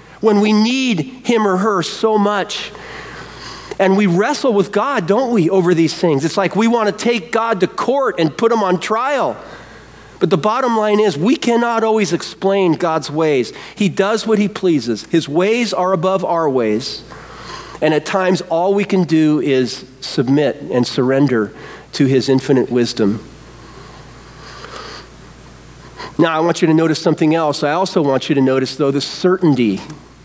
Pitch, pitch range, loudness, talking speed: 180 Hz, 145-210 Hz, -16 LUFS, 170 wpm